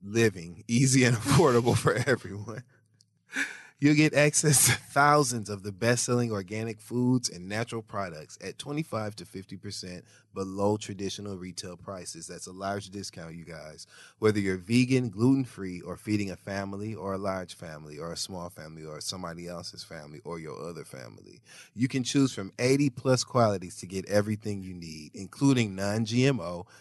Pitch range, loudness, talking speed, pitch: 95-120 Hz, -28 LUFS, 165 wpm, 105 Hz